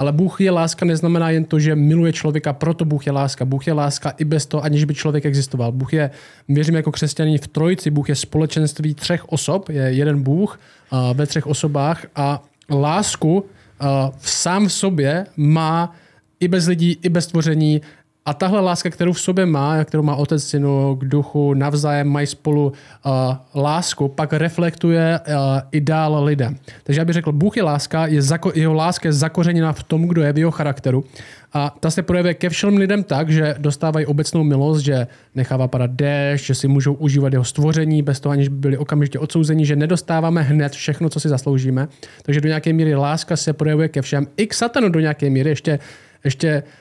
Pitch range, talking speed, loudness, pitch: 140-165 Hz, 195 wpm, -18 LUFS, 150 Hz